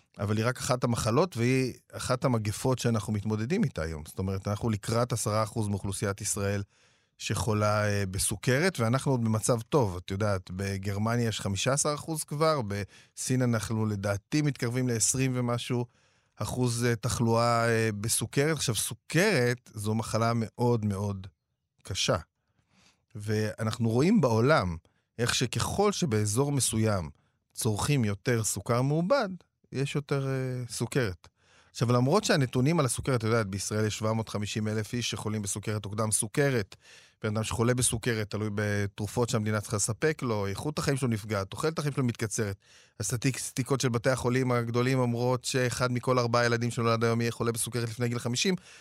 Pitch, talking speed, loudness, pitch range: 115 Hz, 145 wpm, -29 LUFS, 105-125 Hz